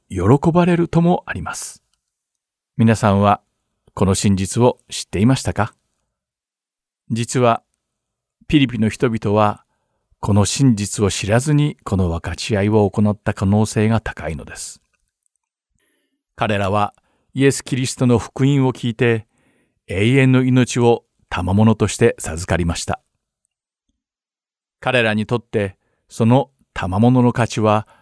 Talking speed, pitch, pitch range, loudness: 240 characters per minute, 115 Hz, 105-125 Hz, -18 LUFS